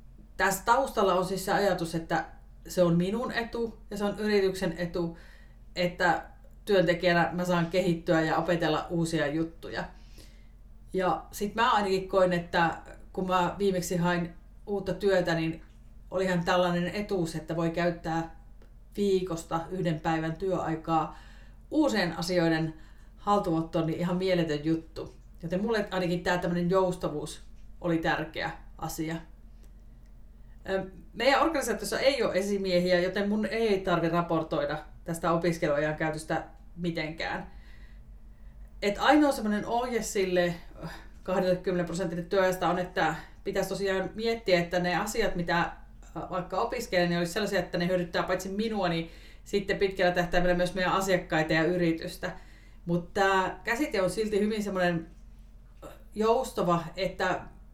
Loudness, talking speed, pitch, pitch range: -29 LUFS, 125 wpm, 180 Hz, 170-195 Hz